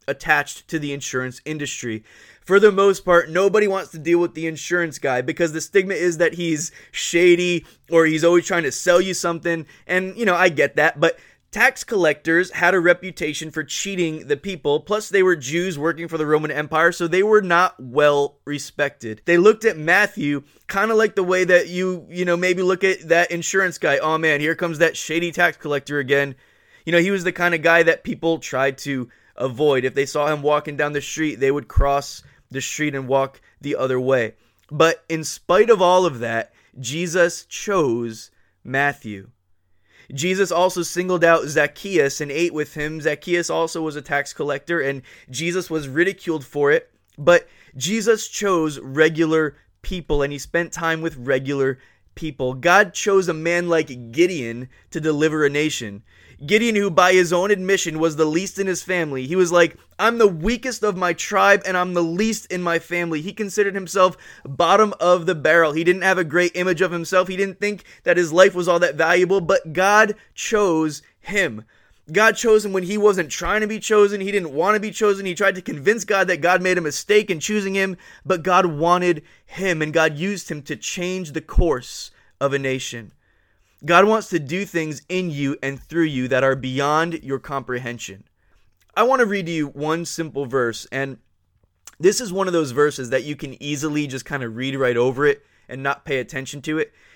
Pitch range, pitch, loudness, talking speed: 145-185 Hz, 165 Hz, -20 LUFS, 200 wpm